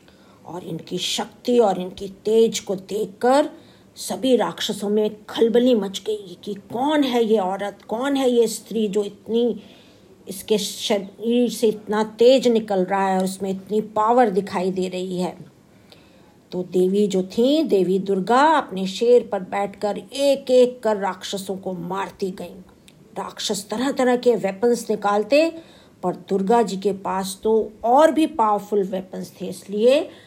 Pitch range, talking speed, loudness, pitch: 190-235 Hz, 150 wpm, -21 LUFS, 210 Hz